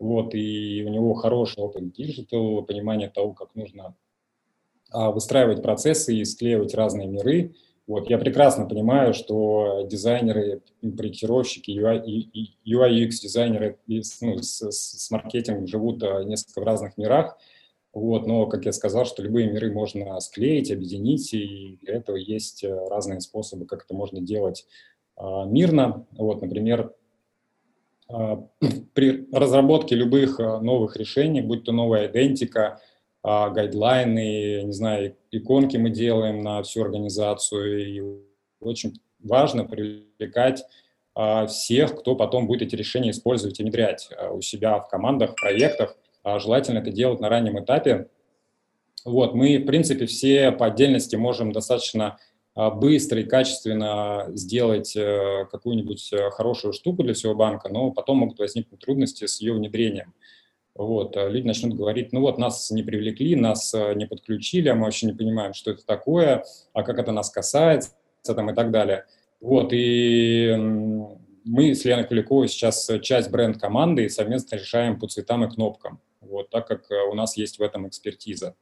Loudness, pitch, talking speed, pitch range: -23 LUFS, 110 Hz, 140 wpm, 105-120 Hz